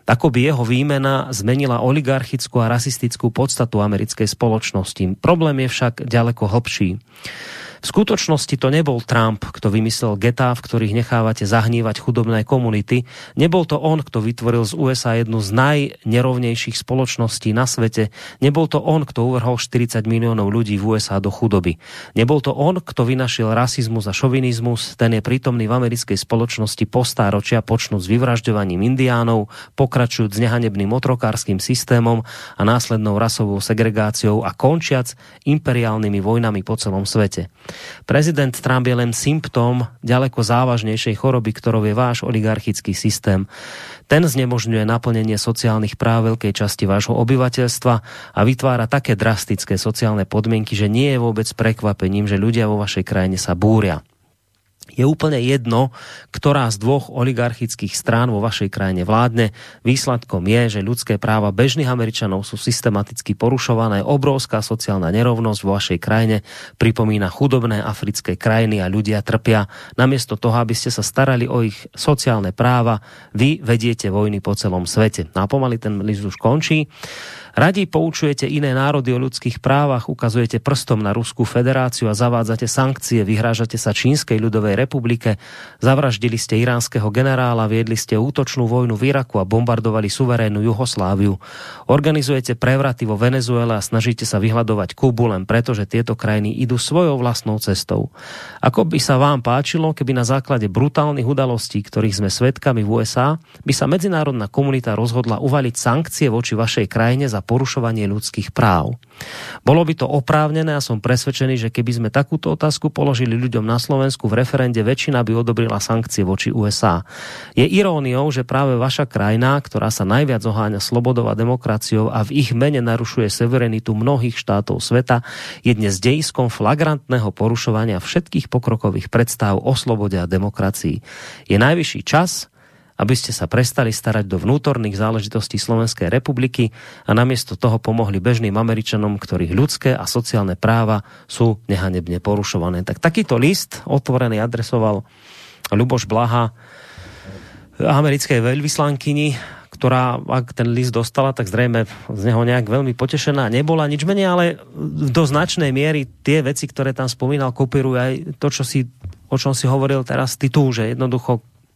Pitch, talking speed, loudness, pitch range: 120 Hz, 145 wpm, -18 LUFS, 110-130 Hz